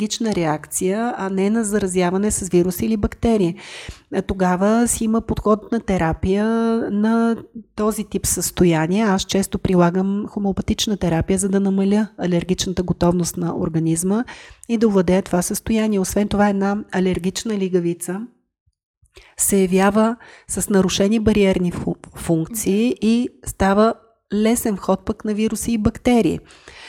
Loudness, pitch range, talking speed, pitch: -19 LUFS, 185-220 Hz, 125 wpm, 200 Hz